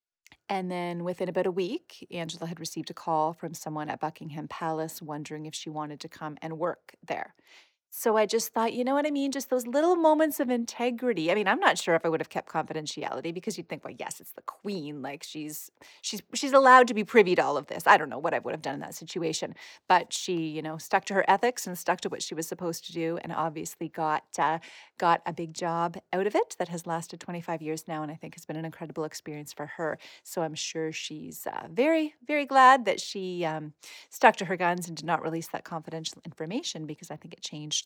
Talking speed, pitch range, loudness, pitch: 245 wpm, 160-195 Hz, -28 LUFS, 170 Hz